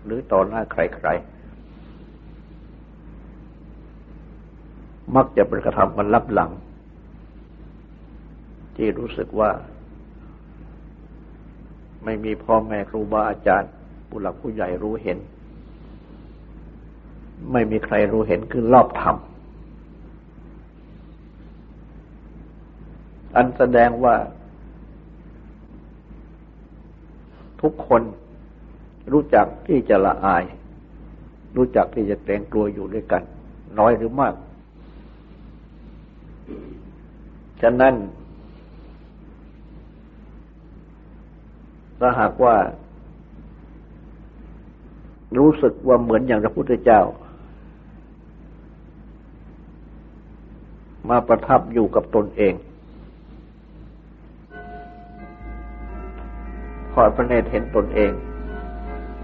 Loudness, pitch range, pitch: -20 LUFS, 80-115 Hz, 105 Hz